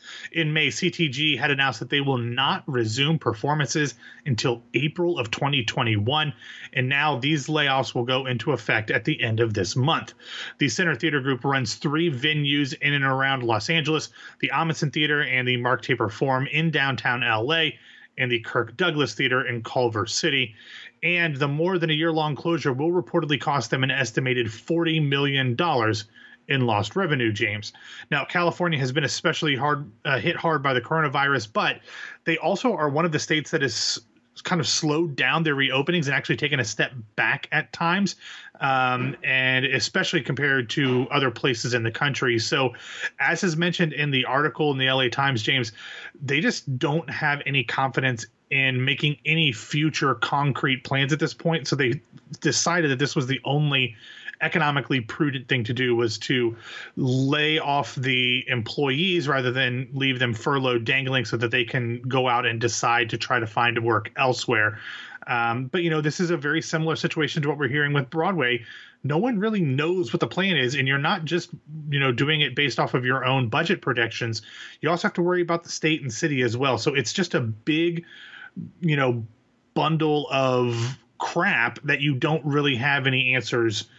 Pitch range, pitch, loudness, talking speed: 125-155 Hz, 140 Hz, -23 LUFS, 185 wpm